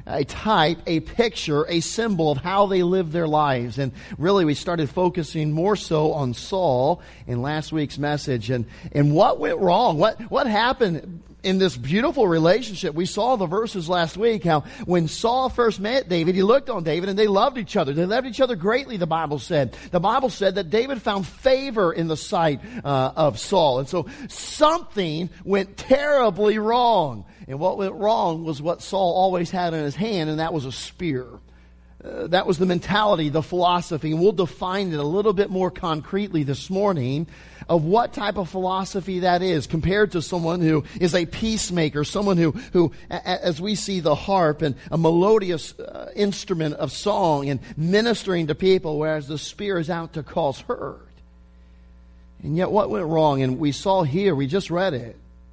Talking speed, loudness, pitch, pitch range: 190 wpm, -22 LUFS, 175 Hz, 155-200 Hz